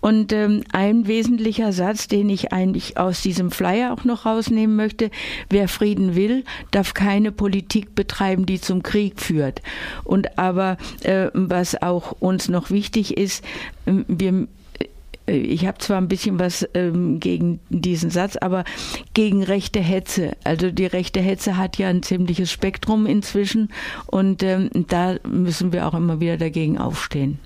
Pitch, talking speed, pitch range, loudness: 190 Hz, 145 wpm, 180-210 Hz, -21 LUFS